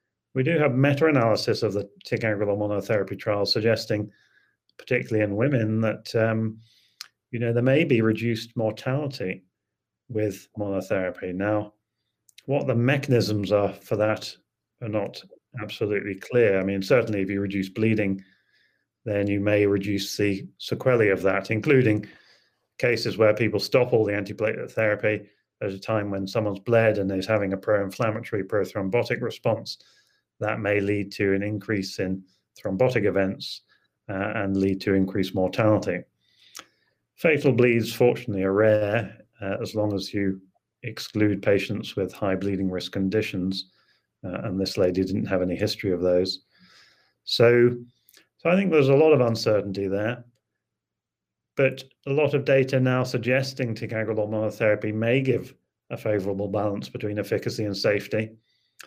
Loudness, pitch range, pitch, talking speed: -24 LUFS, 100-115 Hz, 105 Hz, 145 wpm